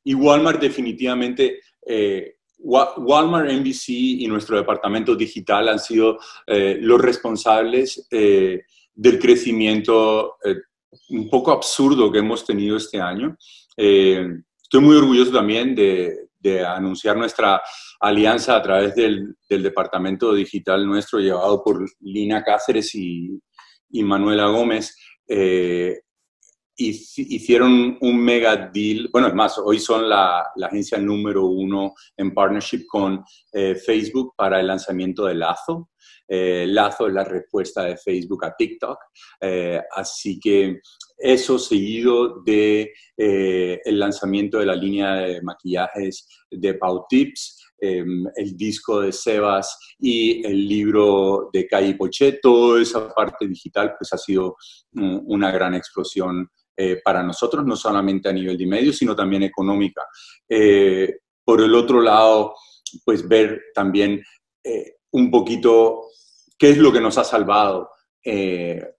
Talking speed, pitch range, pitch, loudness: 135 wpm, 95-125 Hz, 105 Hz, -19 LUFS